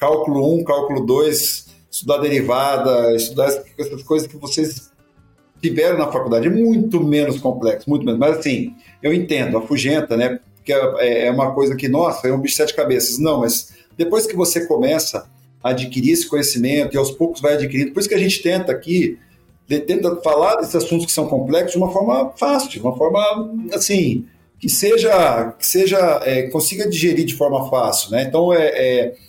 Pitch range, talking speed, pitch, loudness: 130-170 Hz, 185 wpm, 145 Hz, -17 LUFS